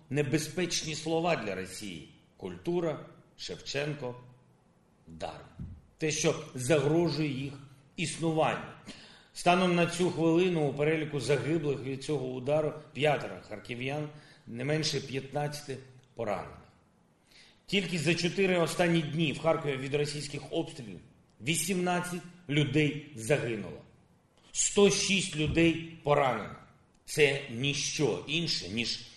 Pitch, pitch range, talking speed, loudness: 150 Hz, 135-165 Hz, 95 wpm, -30 LUFS